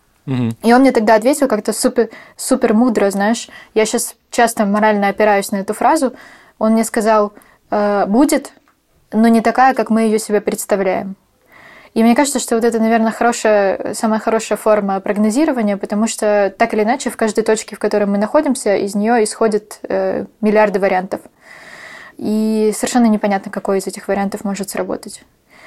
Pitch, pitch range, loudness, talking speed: 220 Hz, 205-235 Hz, -15 LUFS, 160 wpm